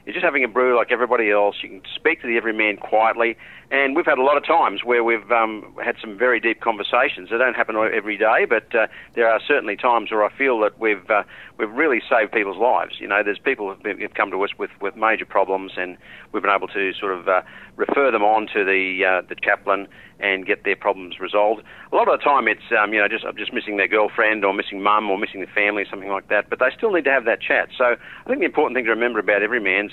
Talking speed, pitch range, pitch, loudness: 260 wpm, 100-115 Hz, 105 Hz, -20 LUFS